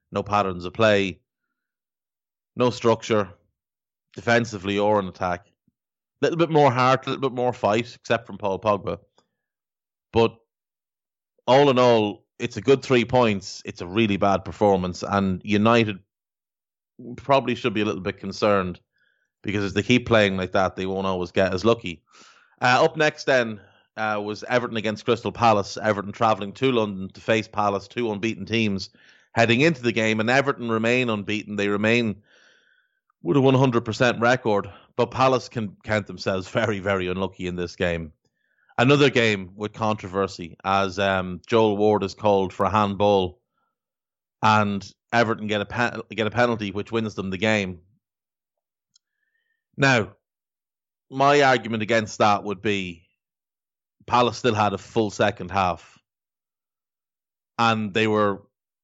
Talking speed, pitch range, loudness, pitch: 155 wpm, 100-120 Hz, -22 LUFS, 110 Hz